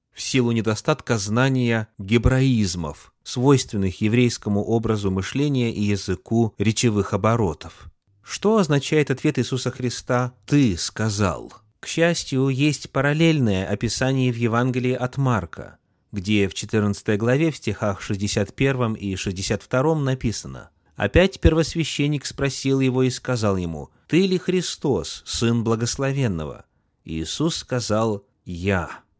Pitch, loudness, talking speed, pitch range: 120 Hz, -22 LUFS, 110 wpm, 105-135 Hz